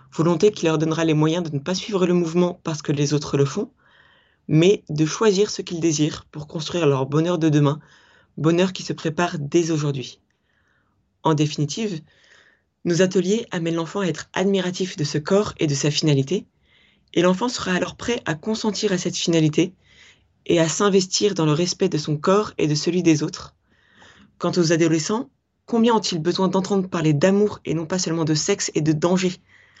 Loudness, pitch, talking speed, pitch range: -21 LUFS, 170 Hz, 190 wpm, 155-190 Hz